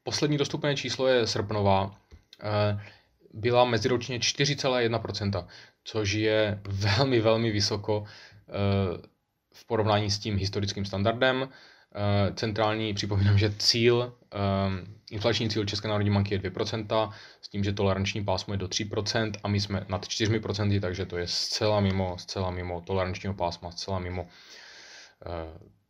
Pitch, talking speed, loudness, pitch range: 105 Hz, 125 wpm, -28 LUFS, 95-110 Hz